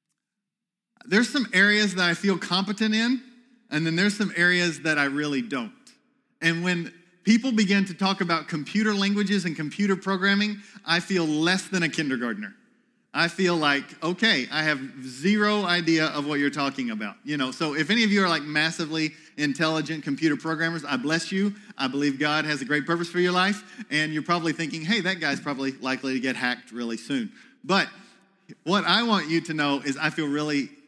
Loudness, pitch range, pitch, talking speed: -24 LUFS, 150-205 Hz, 170 Hz, 190 wpm